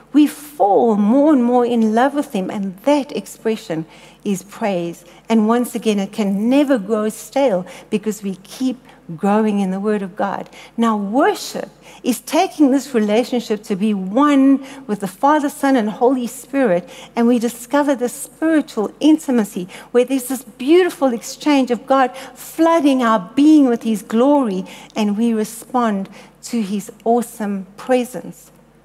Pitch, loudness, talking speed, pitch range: 240 Hz, -17 LUFS, 150 wpm, 215-270 Hz